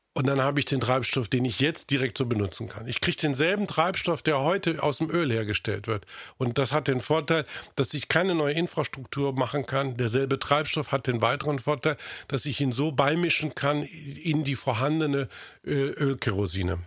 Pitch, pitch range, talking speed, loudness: 140 Hz, 130-155 Hz, 185 wpm, -26 LUFS